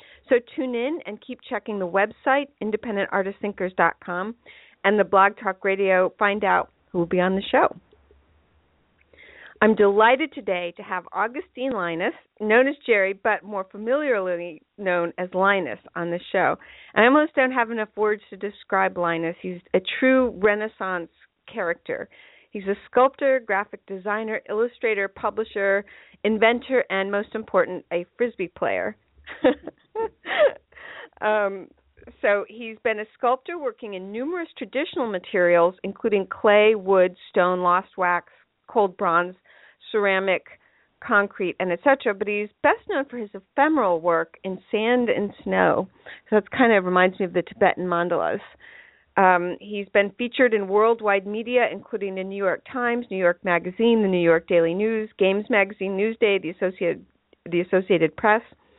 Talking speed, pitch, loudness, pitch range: 145 wpm, 205 Hz, -23 LUFS, 185-230 Hz